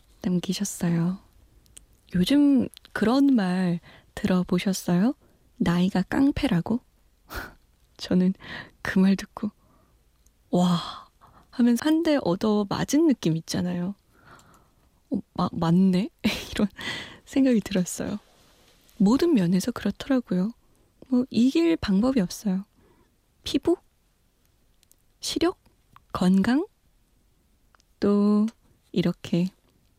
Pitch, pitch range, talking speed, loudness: 195 Hz, 180-245 Hz, 170 characters per minute, -25 LUFS